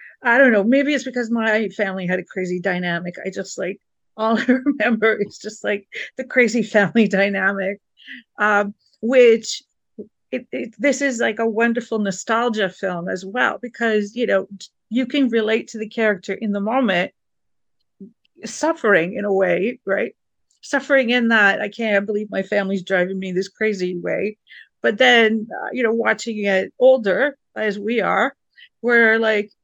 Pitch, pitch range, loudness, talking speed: 220 Hz, 195-240 Hz, -19 LUFS, 165 wpm